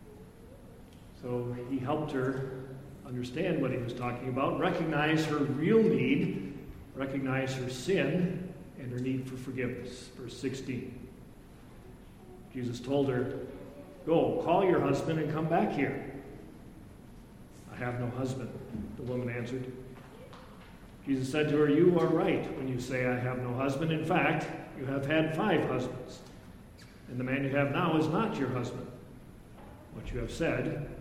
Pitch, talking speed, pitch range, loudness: 130 Hz, 150 wpm, 125-150 Hz, -31 LUFS